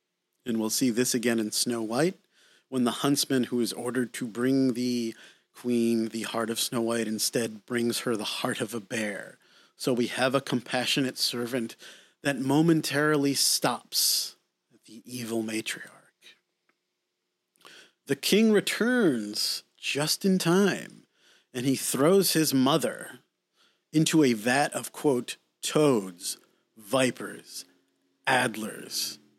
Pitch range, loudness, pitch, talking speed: 115-140 Hz, -27 LUFS, 125 Hz, 130 wpm